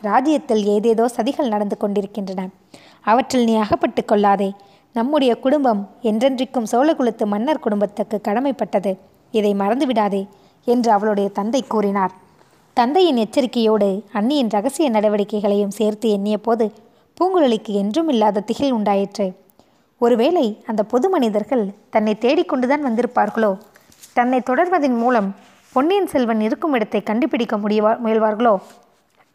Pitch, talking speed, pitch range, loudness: 225 Hz, 105 wpm, 210-255 Hz, -19 LUFS